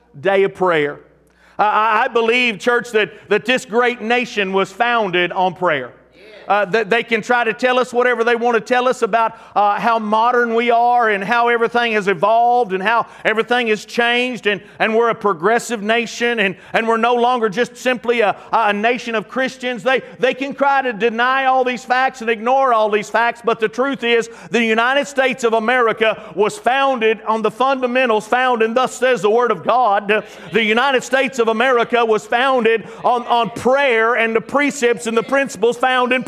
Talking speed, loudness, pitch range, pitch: 195 wpm, -16 LUFS, 215-245 Hz, 235 Hz